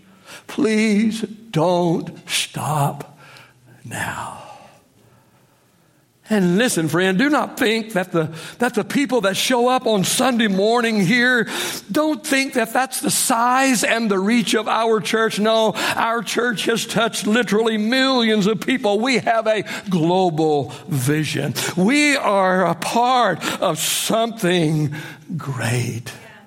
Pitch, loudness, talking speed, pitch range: 215 Hz, -18 LUFS, 125 wpm, 175-240 Hz